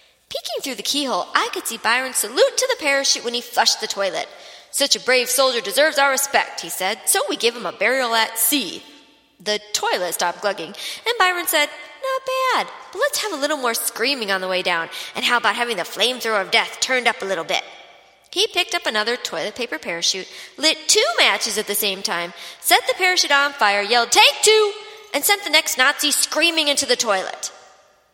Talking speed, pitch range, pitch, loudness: 205 wpm, 205-310 Hz, 250 Hz, -18 LUFS